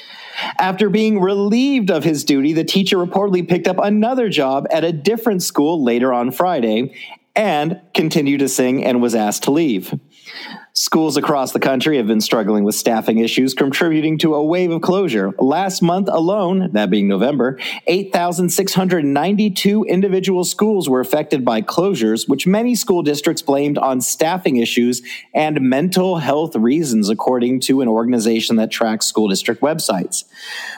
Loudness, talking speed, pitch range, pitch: -16 LUFS, 155 wpm, 130-190 Hz, 160 Hz